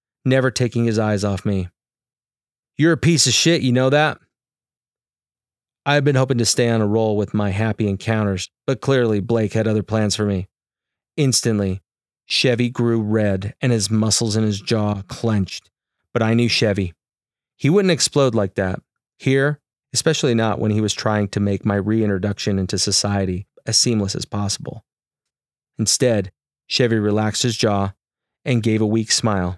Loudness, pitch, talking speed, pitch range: -19 LUFS, 110 Hz, 165 wpm, 105-125 Hz